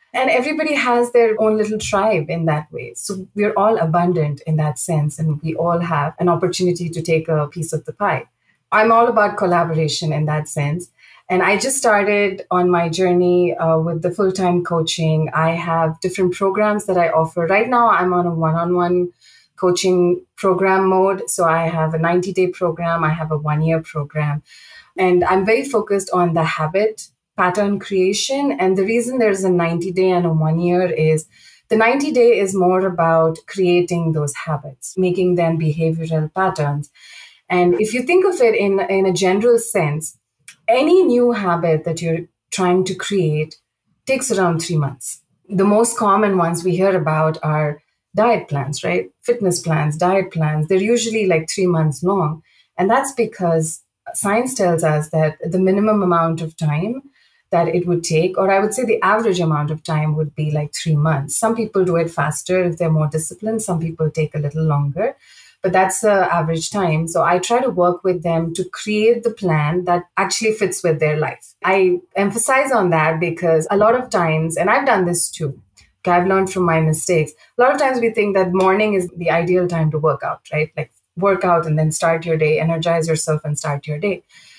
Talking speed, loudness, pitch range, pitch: 195 wpm, -17 LUFS, 160-195 Hz, 175 Hz